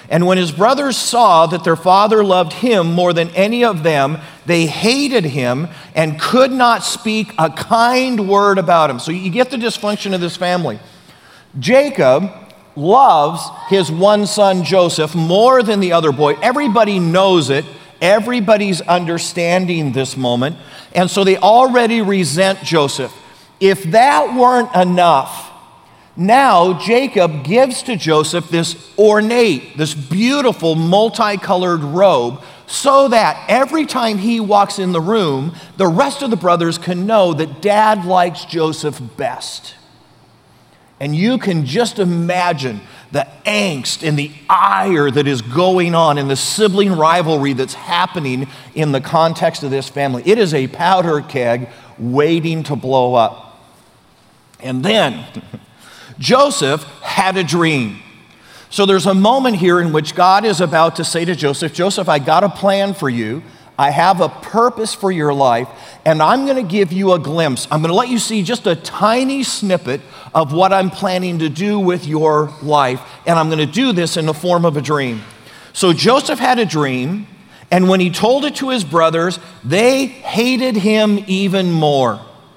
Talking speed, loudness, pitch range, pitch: 160 wpm, -14 LUFS, 155-210 Hz, 180 Hz